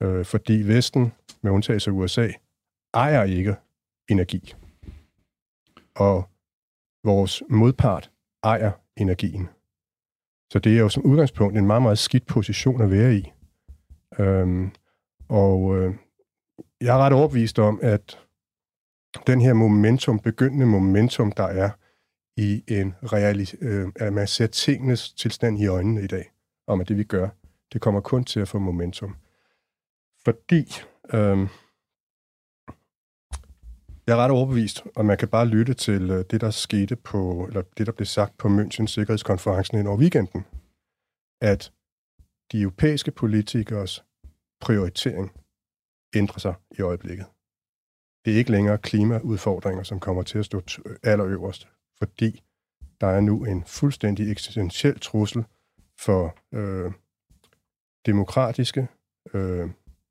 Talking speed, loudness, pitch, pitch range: 125 wpm, -23 LUFS, 105 Hz, 95-115 Hz